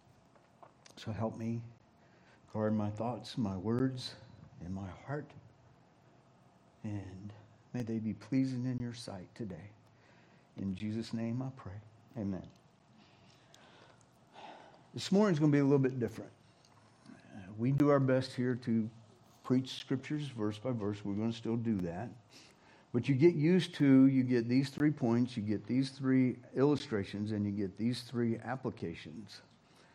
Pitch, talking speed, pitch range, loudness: 120 Hz, 145 wpm, 105-130 Hz, -34 LUFS